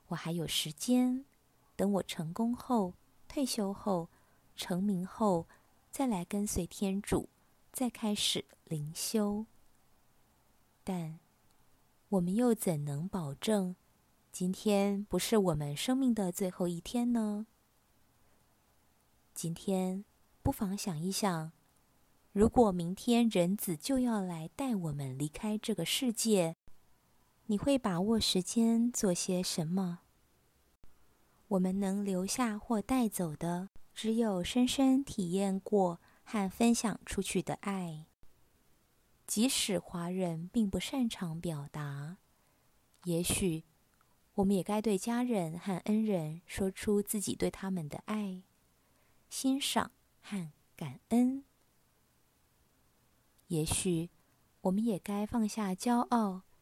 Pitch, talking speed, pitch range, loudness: 190 Hz, 160 characters per minute, 170-220 Hz, -33 LUFS